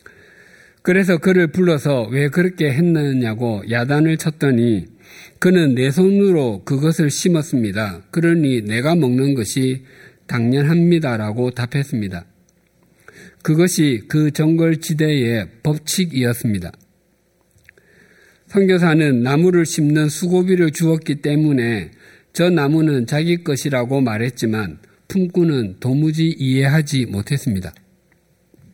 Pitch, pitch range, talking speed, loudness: 145 Hz, 125-165 Hz, 255 characters per minute, -17 LUFS